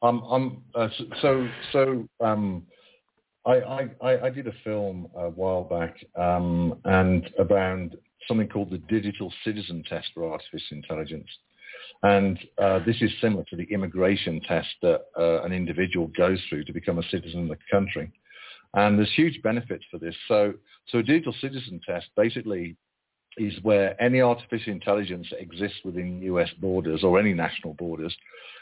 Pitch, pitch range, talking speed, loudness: 100 Hz, 85-115 Hz, 155 wpm, -26 LUFS